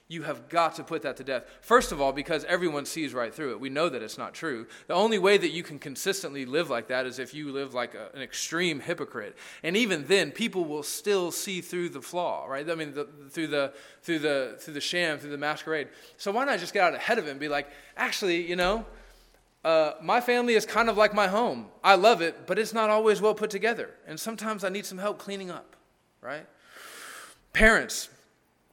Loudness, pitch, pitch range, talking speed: -27 LUFS, 175 Hz, 150-210 Hz, 230 wpm